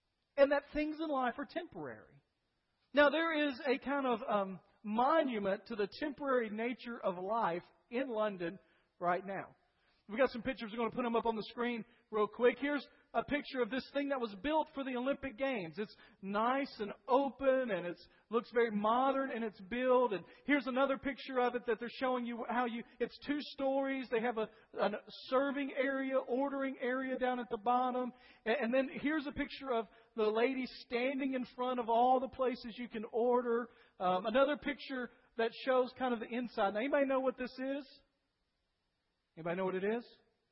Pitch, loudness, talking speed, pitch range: 245 Hz, -36 LUFS, 195 wpm, 230-270 Hz